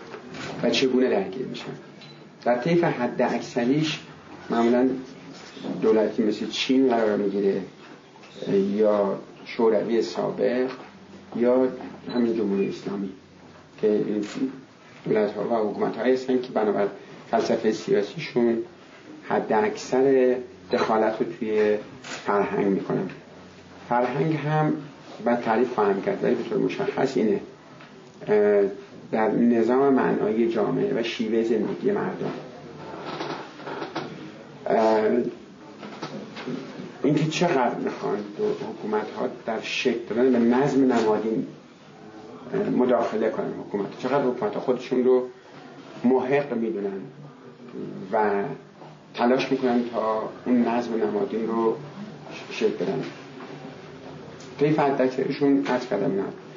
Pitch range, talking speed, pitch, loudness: 110-135 Hz, 95 wpm, 125 Hz, -24 LUFS